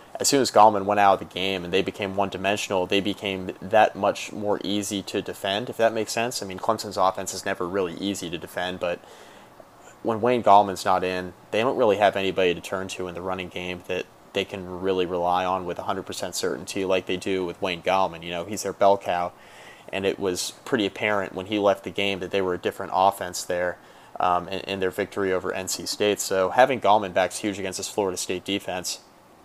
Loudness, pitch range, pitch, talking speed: -25 LUFS, 90-100 Hz, 95 Hz, 225 wpm